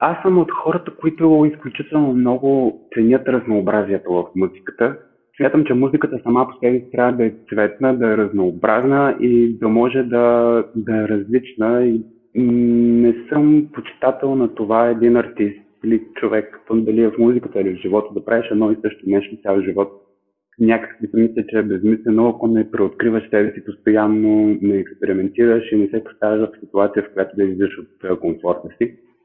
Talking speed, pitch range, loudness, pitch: 175 wpm, 105-125 Hz, -17 LUFS, 115 Hz